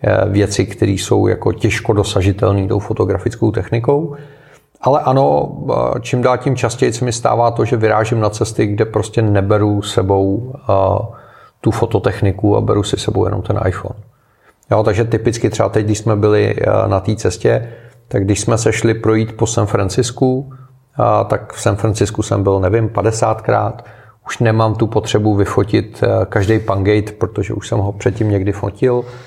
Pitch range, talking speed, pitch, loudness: 105-120 Hz, 160 wpm, 110 Hz, -15 LUFS